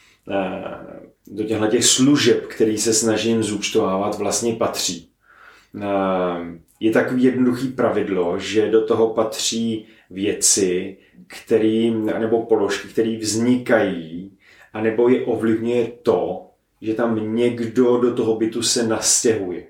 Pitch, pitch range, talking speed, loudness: 110 Hz, 105-115 Hz, 105 wpm, -19 LUFS